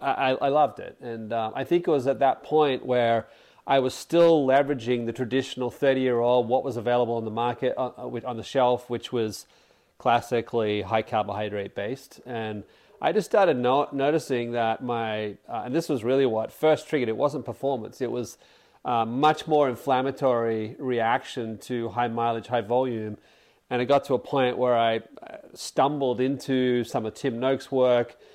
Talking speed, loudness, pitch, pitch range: 180 wpm, -25 LUFS, 125 Hz, 115-135 Hz